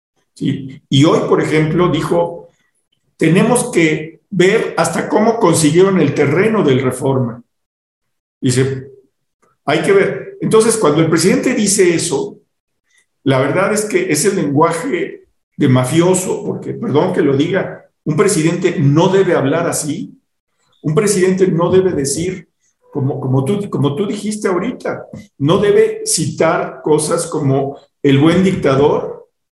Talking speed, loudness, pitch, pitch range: 135 wpm, -14 LUFS, 170 Hz, 145-195 Hz